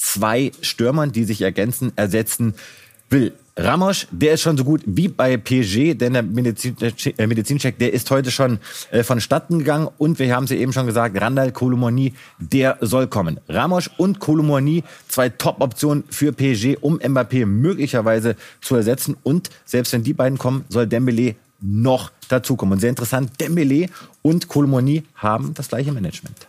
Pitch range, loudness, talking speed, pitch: 120-150 Hz, -19 LUFS, 160 wpm, 130 Hz